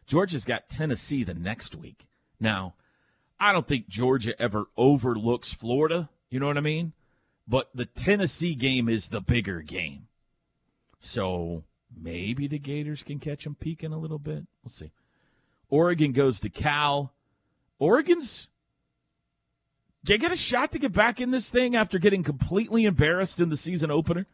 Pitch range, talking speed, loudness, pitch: 120-170 Hz, 155 wpm, -26 LUFS, 145 Hz